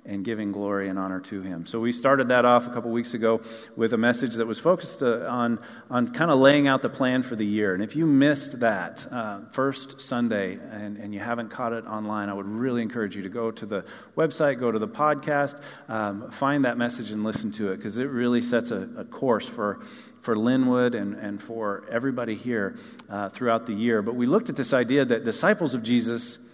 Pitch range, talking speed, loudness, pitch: 110-130 Hz, 225 wpm, -25 LUFS, 120 Hz